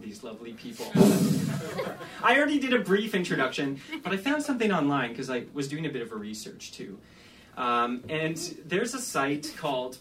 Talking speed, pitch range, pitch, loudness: 180 wpm, 135-225 Hz, 155 Hz, -27 LUFS